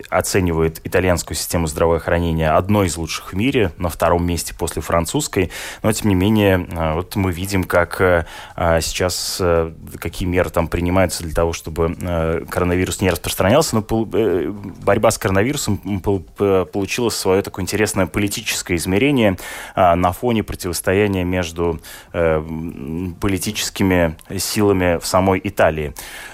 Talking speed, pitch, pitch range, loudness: 120 wpm, 90 Hz, 85-100 Hz, -19 LUFS